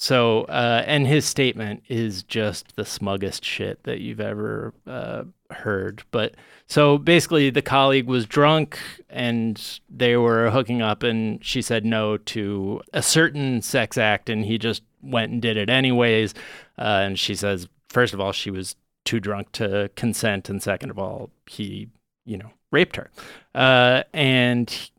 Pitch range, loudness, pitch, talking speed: 105-130 Hz, -21 LUFS, 115 Hz, 165 wpm